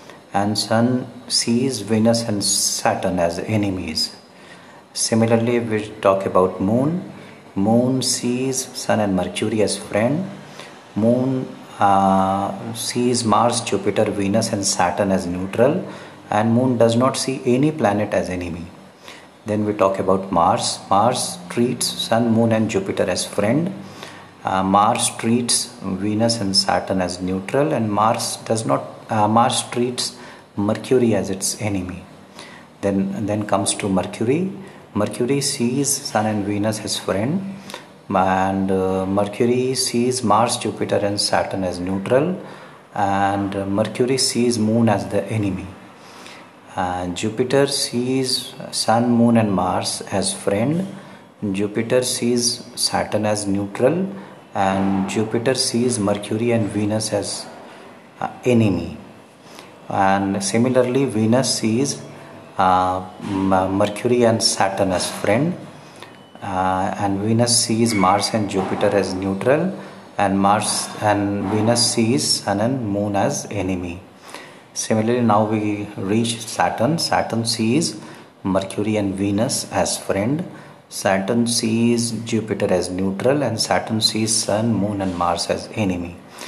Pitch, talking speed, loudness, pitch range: 105 Hz, 125 wpm, -20 LUFS, 95-120 Hz